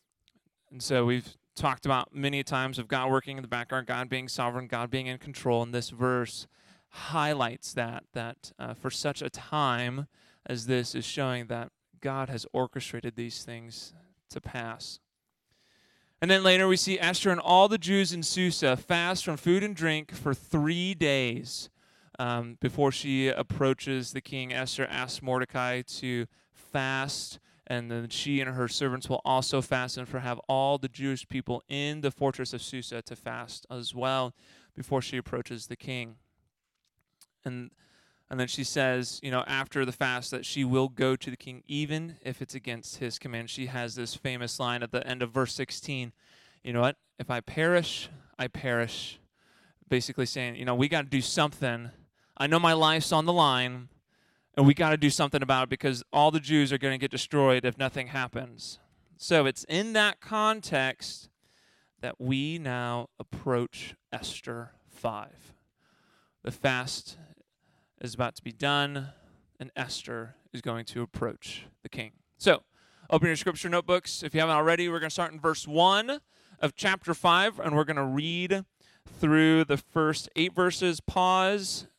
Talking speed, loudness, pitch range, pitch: 175 wpm, -29 LUFS, 125-155 Hz, 135 Hz